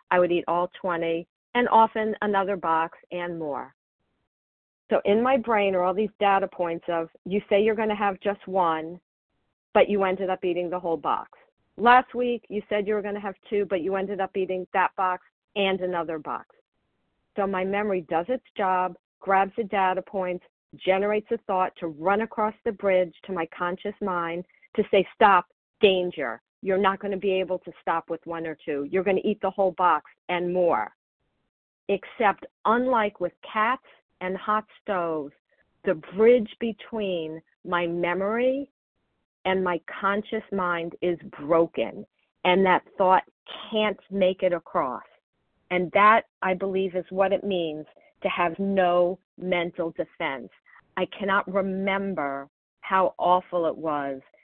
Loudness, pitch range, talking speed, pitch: -25 LUFS, 175-205 Hz, 165 wpm, 190 Hz